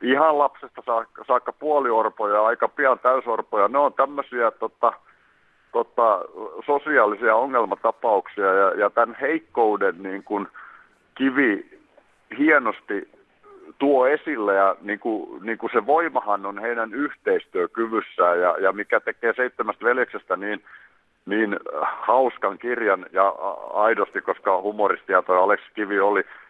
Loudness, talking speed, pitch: -22 LUFS, 120 wpm, 375 Hz